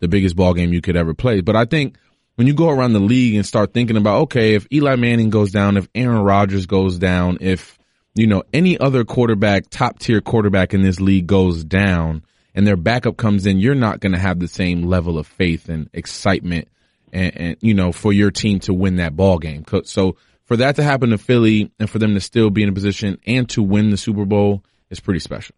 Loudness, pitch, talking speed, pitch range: -17 LUFS, 100 Hz, 235 wpm, 95-115 Hz